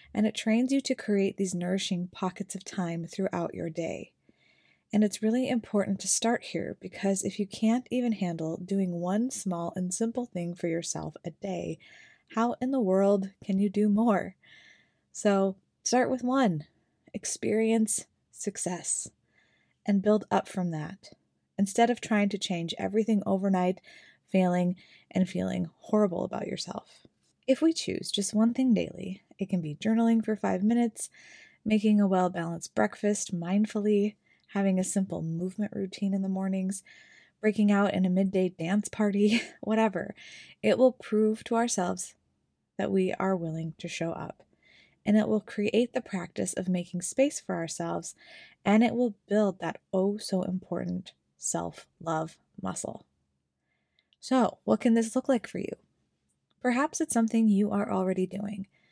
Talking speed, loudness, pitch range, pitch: 155 wpm, -29 LUFS, 180-220 Hz, 200 Hz